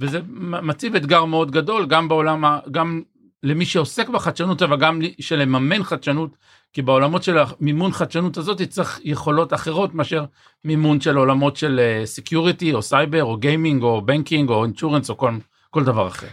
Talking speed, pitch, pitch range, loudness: 160 wpm, 155 Hz, 145-165 Hz, -19 LUFS